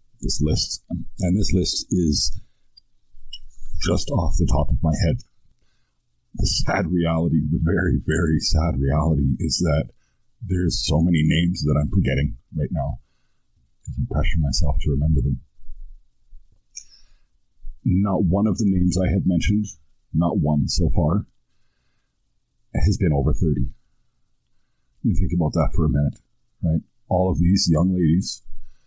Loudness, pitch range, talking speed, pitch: -22 LUFS, 75-95 Hz, 140 wpm, 85 Hz